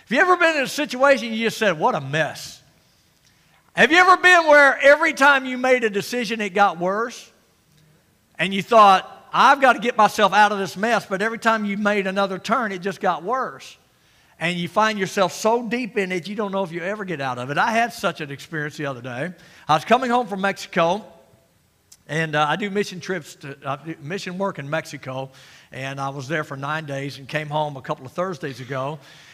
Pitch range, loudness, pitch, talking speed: 155-225 Hz, -20 LUFS, 195 Hz, 225 wpm